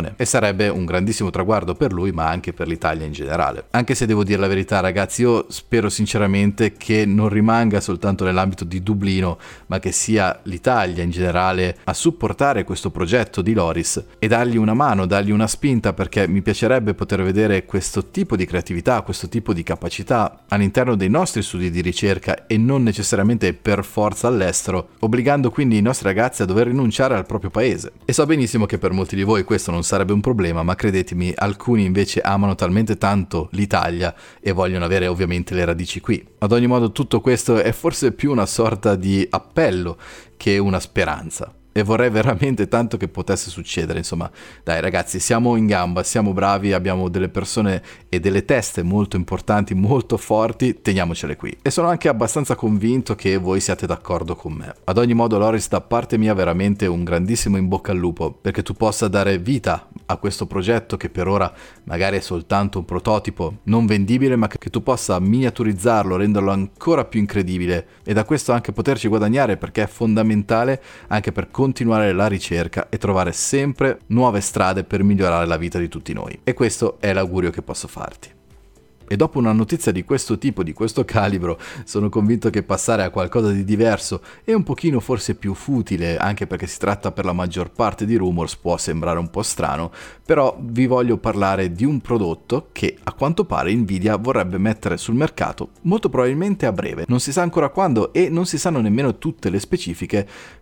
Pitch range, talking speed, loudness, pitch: 95-115 Hz, 185 wpm, -19 LUFS, 100 Hz